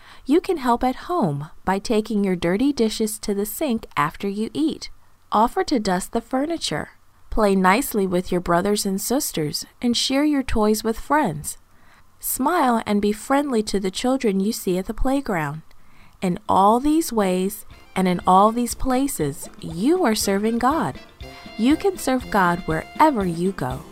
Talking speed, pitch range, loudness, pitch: 165 wpm, 190-260 Hz, -21 LUFS, 220 Hz